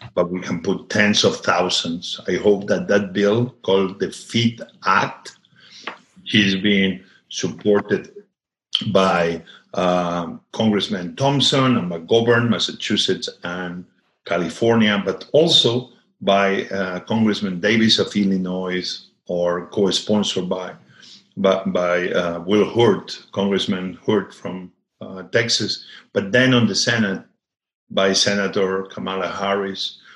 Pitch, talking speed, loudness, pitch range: 95 Hz, 115 wpm, -19 LUFS, 90-110 Hz